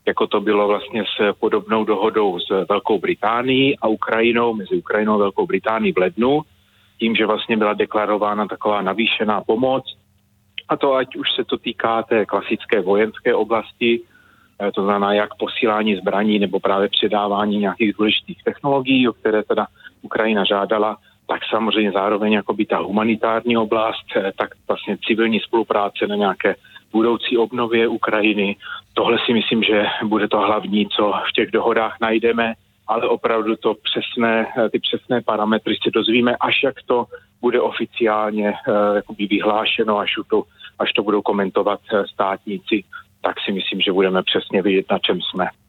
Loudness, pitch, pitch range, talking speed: -19 LUFS, 105 Hz, 105-115 Hz, 150 wpm